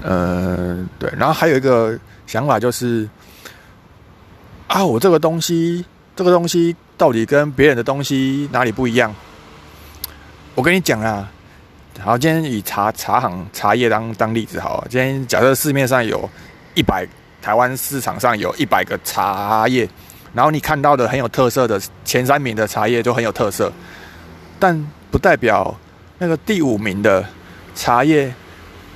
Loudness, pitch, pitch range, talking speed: -17 LUFS, 120 Hz, 95-140 Hz, 230 characters per minute